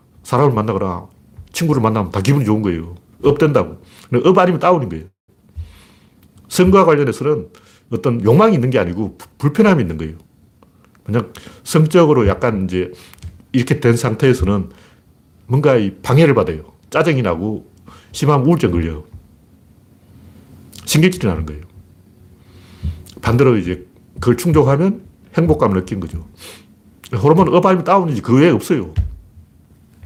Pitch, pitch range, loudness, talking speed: 105 Hz, 90-145 Hz, -15 LUFS, 310 characters per minute